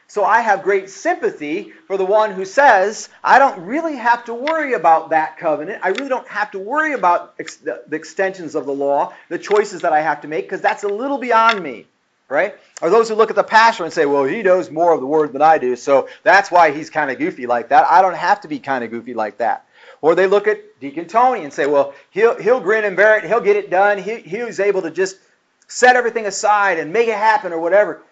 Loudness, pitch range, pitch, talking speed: -16 LUFS, 160-230 Hz, 200 Hz, 255 wpm